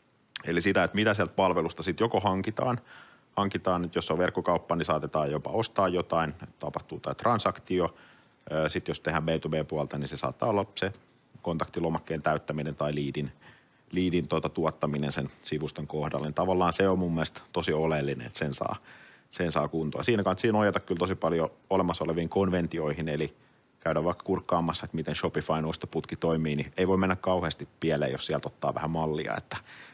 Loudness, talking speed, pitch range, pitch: -30 LUFS, 170 wpm, 75-95 Hz, 80 Hz